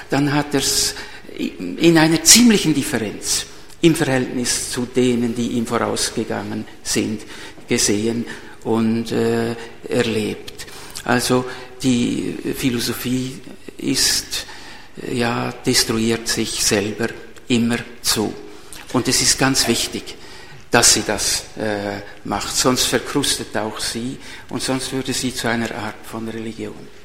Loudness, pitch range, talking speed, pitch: -18 LUFS, 110-130 Hz, 120 wpm, 120 Hz